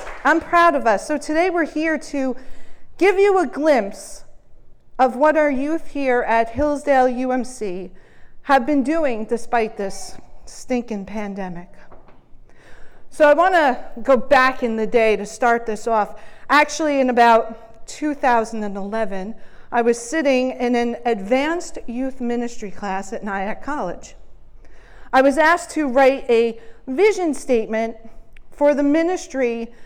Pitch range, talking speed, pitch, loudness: 225-295 Hz, 135 wpm, 255 Hz, -19 LUFS